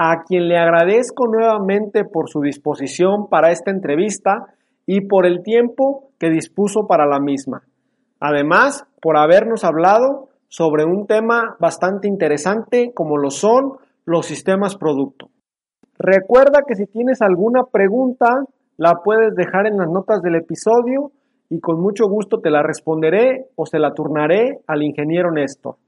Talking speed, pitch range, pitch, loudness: 145 wpm, 165-235 Hz, 195 Hz, -16 LUFS